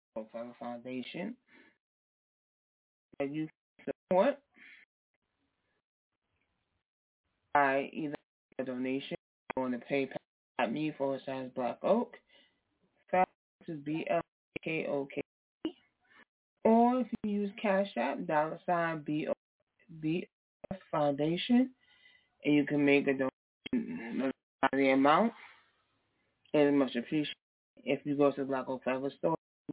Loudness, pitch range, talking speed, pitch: -33 LUFS, 135-190 Hz, 115 wpm, 145 Hz